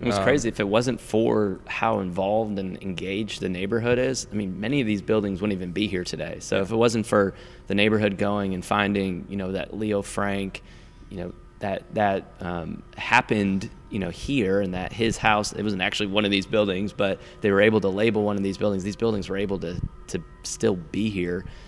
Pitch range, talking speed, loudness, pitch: 95-110 Hz, 215 wpm, -25 LUFS, 100 Hz